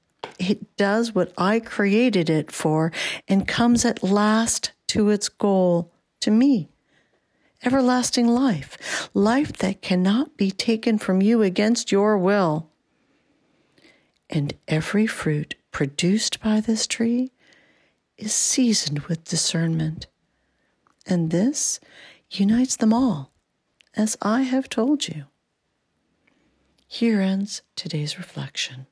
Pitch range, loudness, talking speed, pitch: 175-235 Hz, -22 LUFS, 110 wpm, 205 Hz